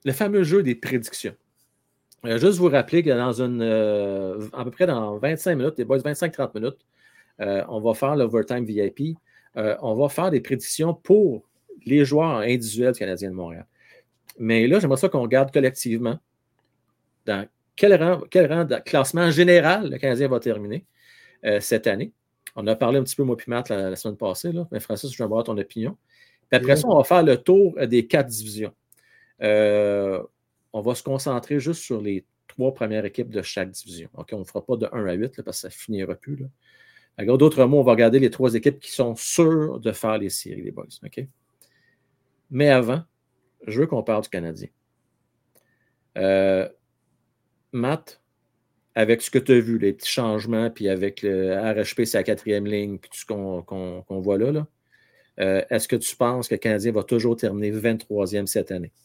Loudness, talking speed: -22 LUFS, 200 wpm